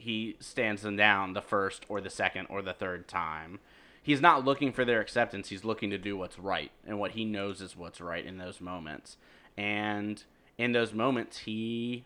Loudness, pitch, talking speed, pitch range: -31 LUFS, 105 Hz, 200 wpm, 95-115 Hz